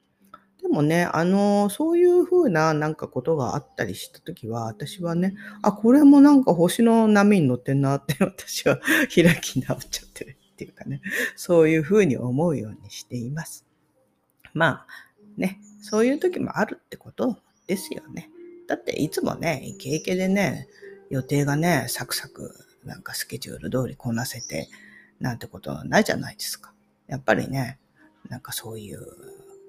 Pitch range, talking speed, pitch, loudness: 135-210 Hz, 335 characters per minute, 170 Hz, -22 LUFS